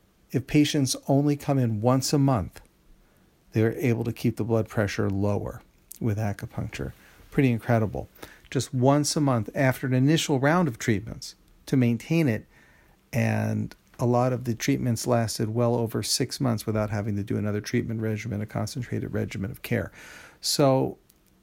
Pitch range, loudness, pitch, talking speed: 110-135 Hz, -26 LUFS, 115 Hz, 160 wpm